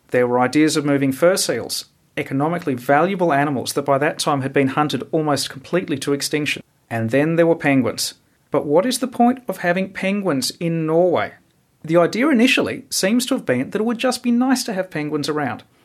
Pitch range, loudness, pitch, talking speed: 140-190 Hz, -19 LUFS, 160 Hz, 200 wpm